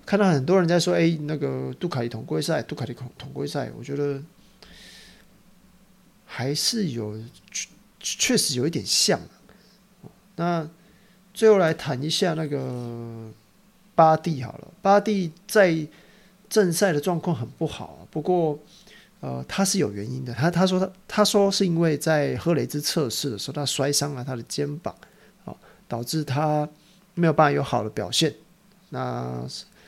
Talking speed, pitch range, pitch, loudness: 220 characters per minute, 140-190 Hz, 160 Hz, -24 LUFS